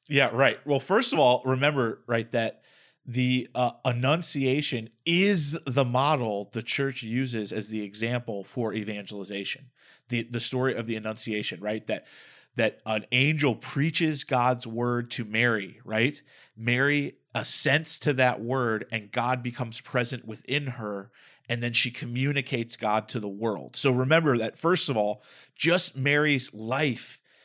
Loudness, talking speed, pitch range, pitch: -26 LUFS, 150 wpm, 110-140 Hz, 125 Hz